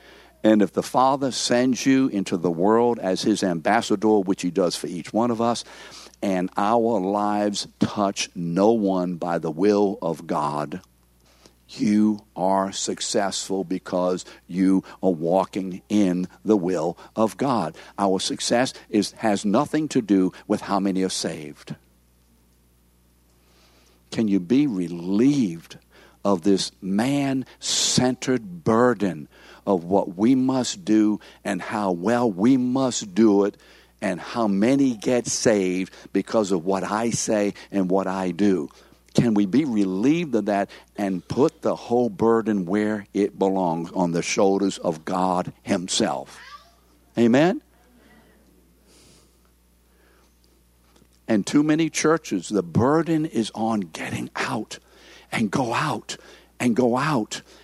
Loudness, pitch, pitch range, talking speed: -23 LUFS, 100 Hz, 90-115 Hz, 130 wpm